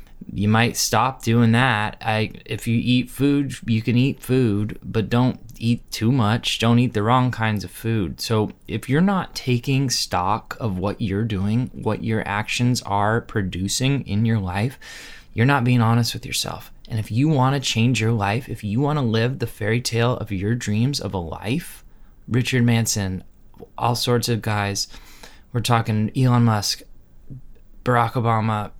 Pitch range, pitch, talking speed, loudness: 105-125 Hz, 115 Hz, 175 wpm, -21 LUFS